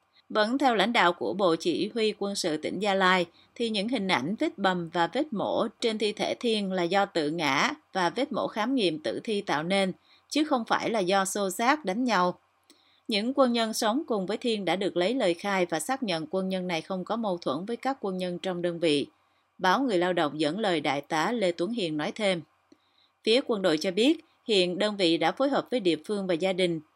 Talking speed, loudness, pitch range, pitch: 240 wpm, -27 LUFS, 175-235 Hz, 195 Hz